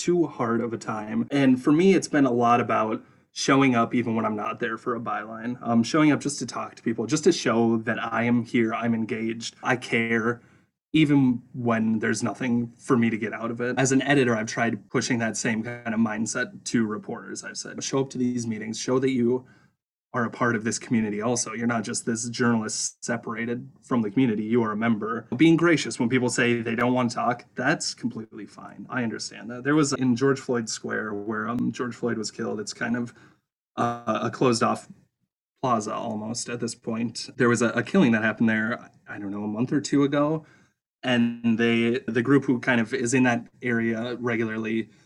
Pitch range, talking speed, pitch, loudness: 115-130 Hz, 215 wpm, 120 Hz, -25 LUFS